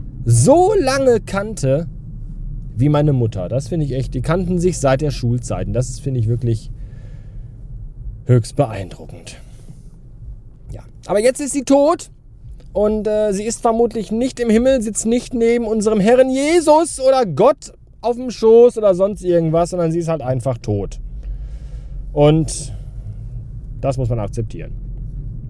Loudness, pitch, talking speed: -17 LUFS, 140 Hz, 145 wpm